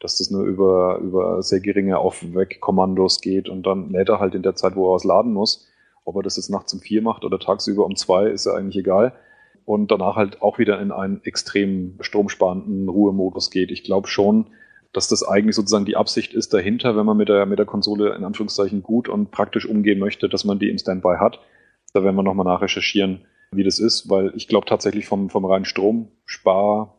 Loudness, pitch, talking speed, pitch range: -20 LUFS, 100 Hz, 215 wpm, 95-105 Hz